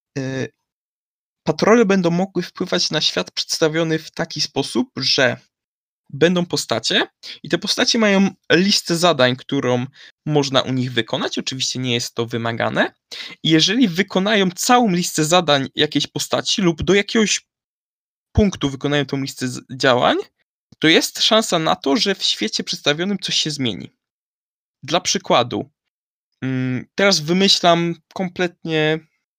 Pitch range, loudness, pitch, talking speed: 135-190 Hz, -18 LUFS, 160 Hz, 125 wpm